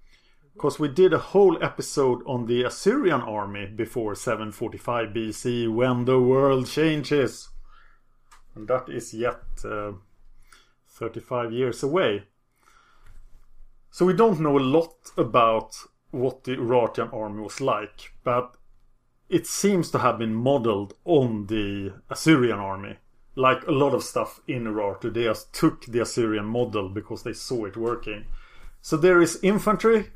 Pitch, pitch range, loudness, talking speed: 120 Hz, 110-140 Hz, -24 LUFS, 140 wpm